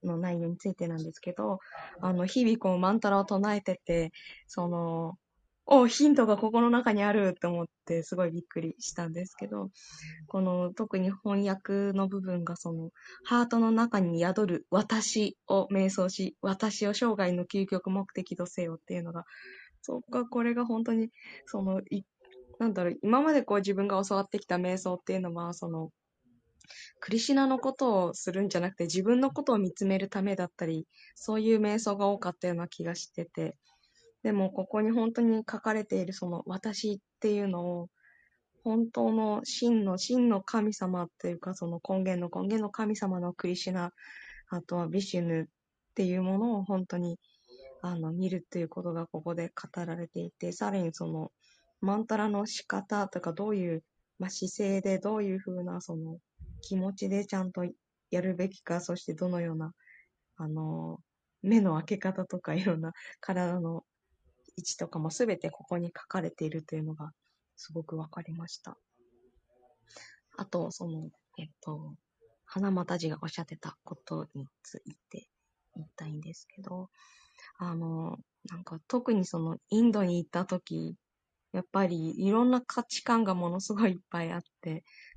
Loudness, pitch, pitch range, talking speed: -31 LUFS, 185 Hz, 170-205 Hz, 325 characters per minute